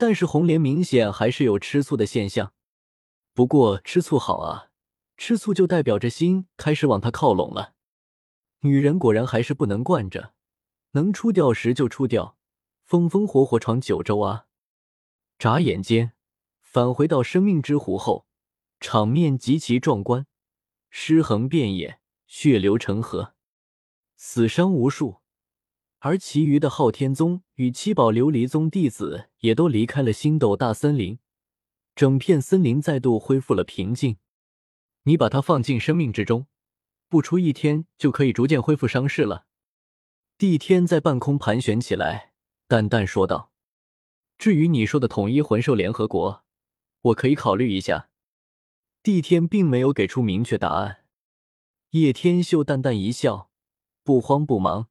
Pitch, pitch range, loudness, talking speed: 130 Hz, 105-155 Hz, -22 LUFS, 220 characters per minute